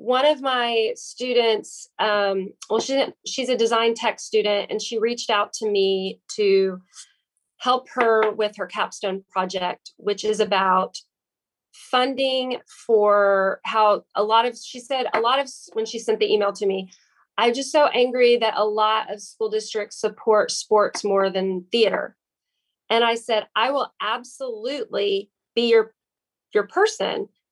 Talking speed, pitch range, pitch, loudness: 155 wpm, 205-250 Hz, 220 Hz, -22 LUFS